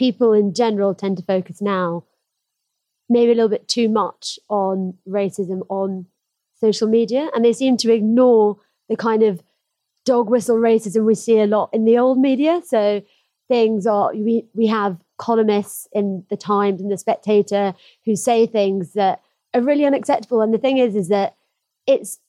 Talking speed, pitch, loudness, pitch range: 170 wpm, 220 Hz, -18 LUFS, 200-235 Hz